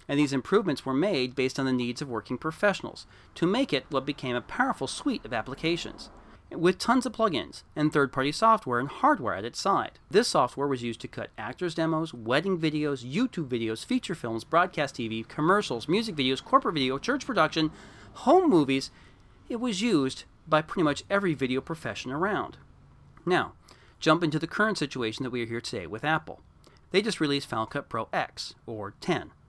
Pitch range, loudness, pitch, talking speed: 130-180 Hz, -28 LUFS, 145 Hz, 185 wpm